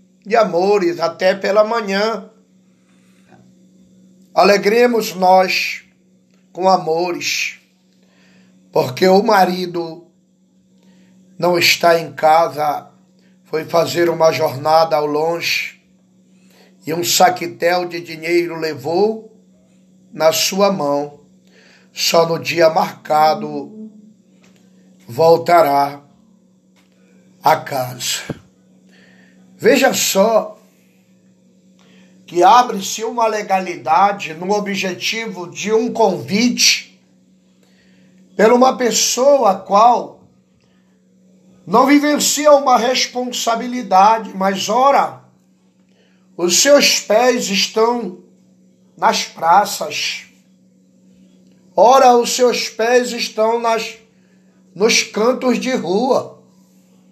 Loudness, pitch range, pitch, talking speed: -15 LUFS, 165-215 Hz, 185 Hz, 80 wpm